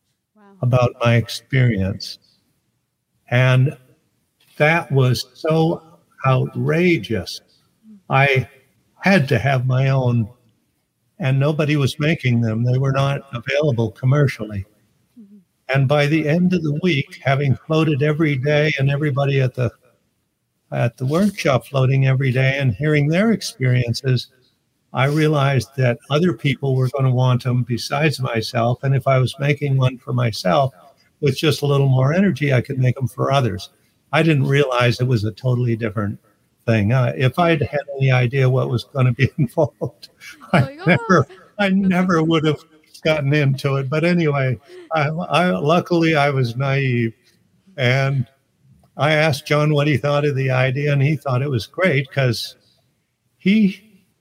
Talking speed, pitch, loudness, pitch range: 155 wpm, 135 Hz, -18 LUFS, 125-150 Hz